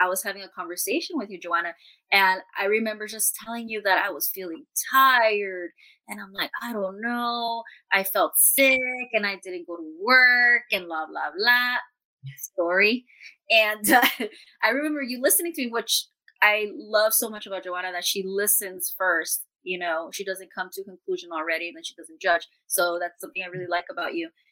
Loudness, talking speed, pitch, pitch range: -23 LUFS, 195 wpm, 200 Hz, 180-245 Hz